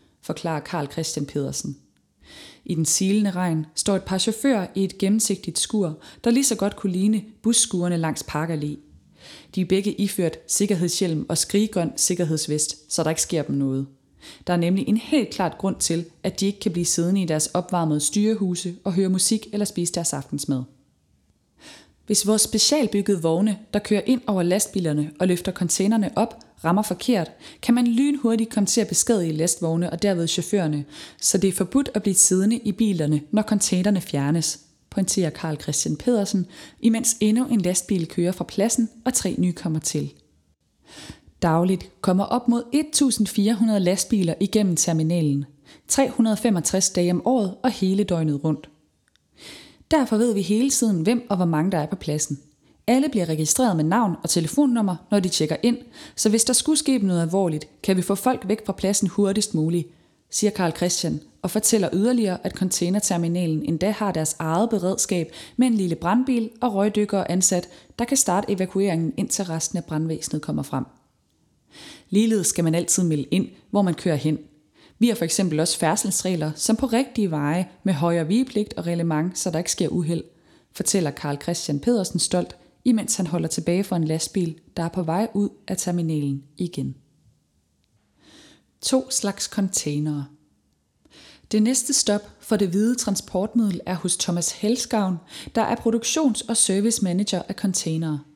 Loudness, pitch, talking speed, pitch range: -22 LUFS, 190 Hz, 170 wpm, 165-215 Hz